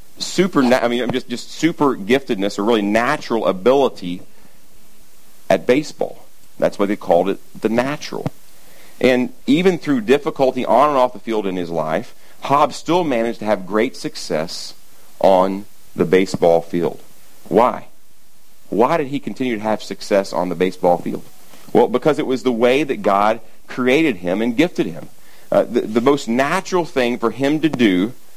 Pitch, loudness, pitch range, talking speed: 115 Hz, -18 LUFS, 100-135 Hz, 165 wpm